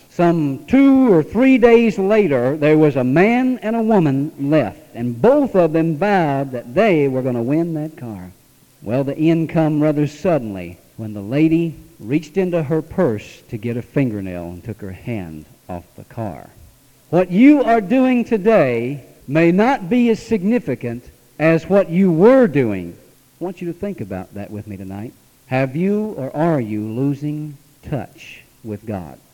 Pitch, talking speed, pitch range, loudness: 150 Hz, 175 wpm, 120-185 Hz, -17 LUFS